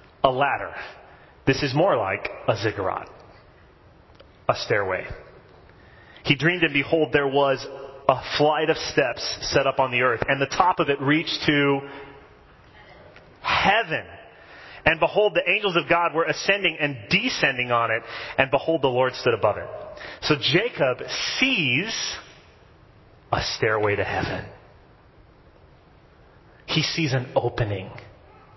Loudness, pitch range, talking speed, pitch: -22 LUFS, 120-160 Hz, 130 wpm, 140 Hz